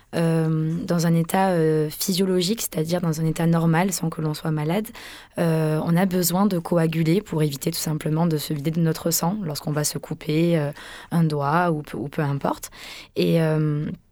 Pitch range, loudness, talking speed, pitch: 155-170 Hz, -23 LUFS, 195 wpm, 165 Hz